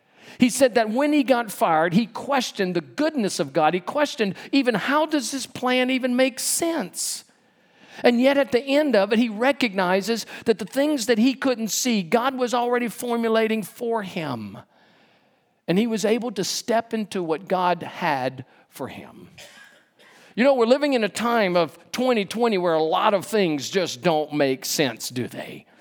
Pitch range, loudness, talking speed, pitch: 190-255 Hz, -22 LUFS, 180 wpm, 230 Hz